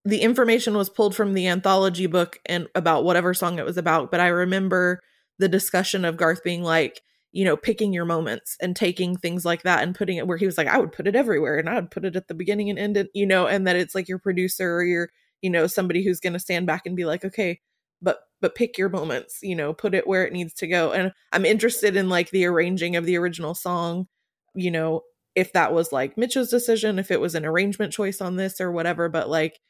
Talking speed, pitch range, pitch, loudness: 245 wpm, 170-195 Hz, 180 Hz, -23 LUFS